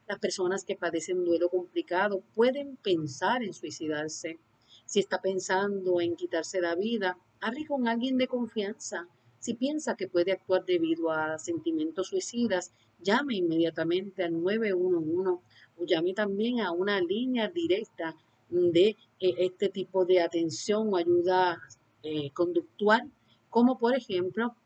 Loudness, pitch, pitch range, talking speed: -29 LUFS, 185 Hz, 170-215 Hz, 135 wpm